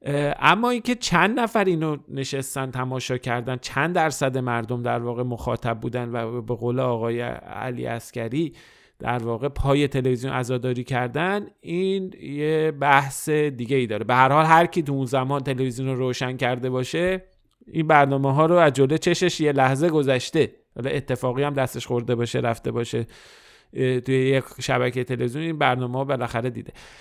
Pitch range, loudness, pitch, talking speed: 125-150 Hz, -23 LUFS, 130 Hz, 155 wpm